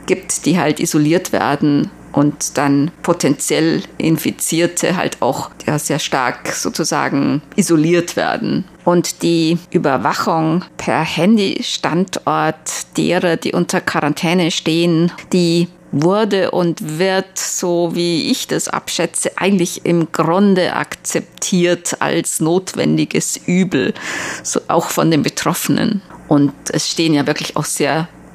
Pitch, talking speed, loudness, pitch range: 170 Hz, 115 wpm, -16 LUFS, 155-180 Hz